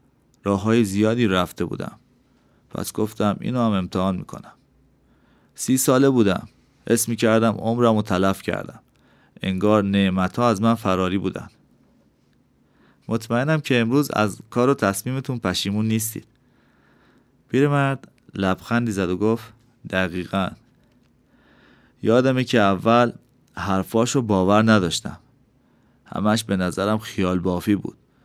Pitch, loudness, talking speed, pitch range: 110 Hz, -21 LUFS, 115 wpm, 95-120 Hz